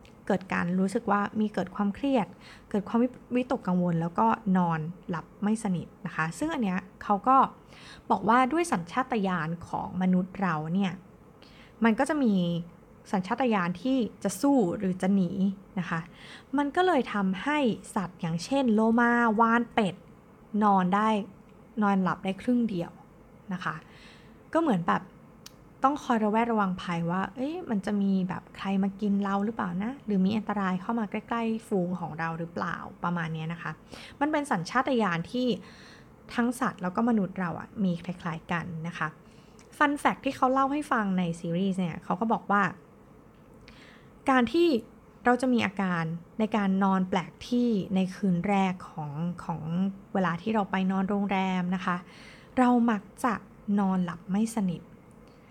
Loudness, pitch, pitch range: -28 LUFS, 200 Hz, 180-230 Hz